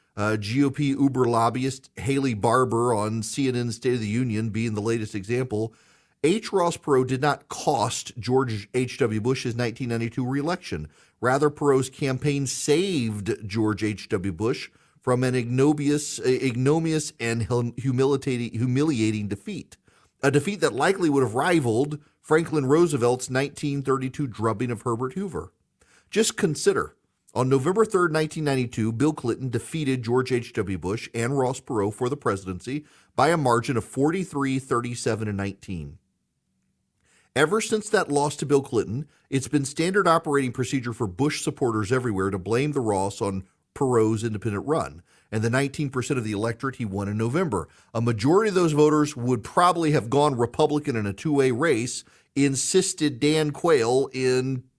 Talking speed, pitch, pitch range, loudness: 145 wpm, 130 Hz, 115-145 Hz, -24 LUFS